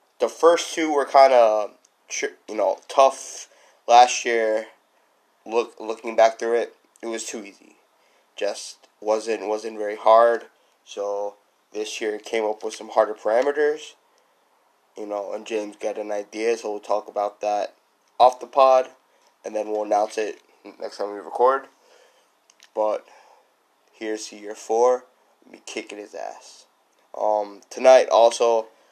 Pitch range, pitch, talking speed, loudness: 105-125 Hz, 110 Hz, 145 wpm, -22 LUFS